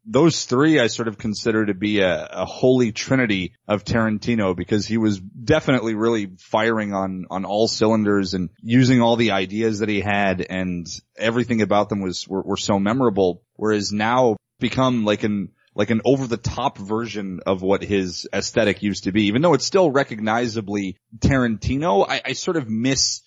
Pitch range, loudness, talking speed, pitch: 100-120 Hz, -21 LUFS, 180 wpm, 110 Hz